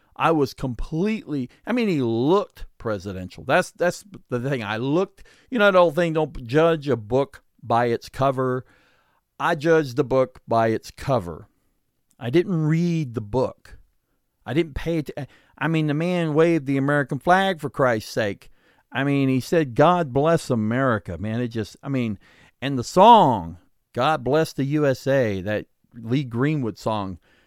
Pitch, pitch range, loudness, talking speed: 135 Hz, 115-160 Hz, -22 LUFS, 170 wpm